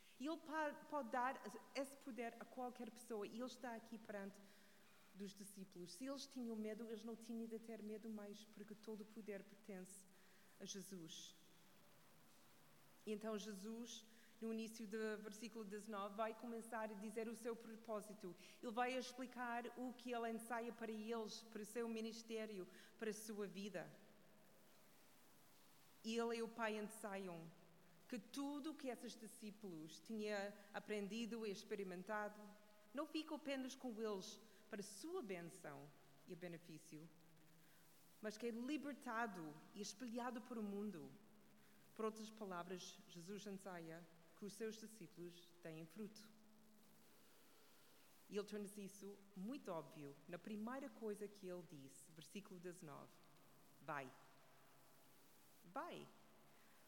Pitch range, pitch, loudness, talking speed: 190-230 Hz, 210 Hz, -52 LUFS, 135 wpm